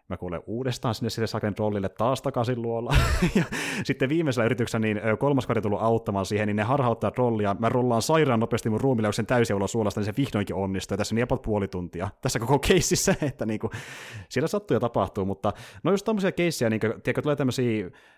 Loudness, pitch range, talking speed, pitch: -26 LUFS, 105-130 Hz, 205 wpm, 115 Hz